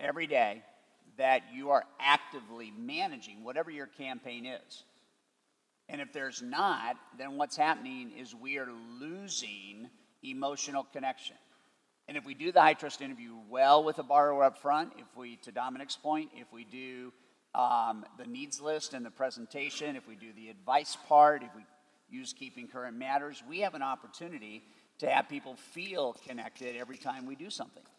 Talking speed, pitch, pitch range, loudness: 170 wpm, 140 Hz, 125-155 Hz, -32 LUFS